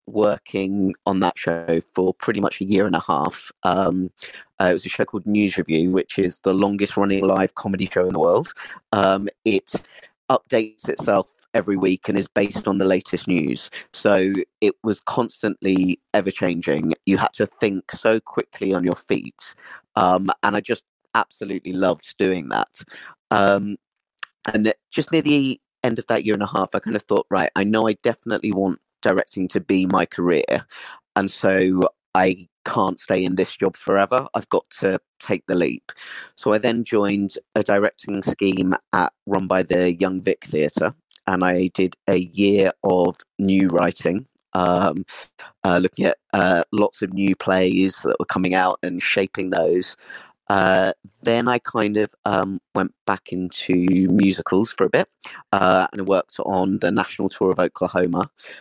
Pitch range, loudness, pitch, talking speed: 95-100 Hz, -21 LUFS, 95 Hz, 175 wpm